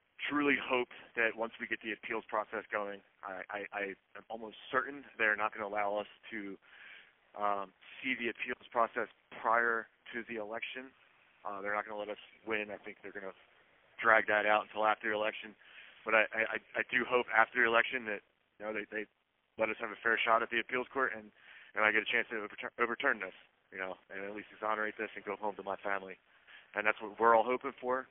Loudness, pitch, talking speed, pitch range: -34 LUFS, 110 Hz, 220 wpm, 105-115 Hz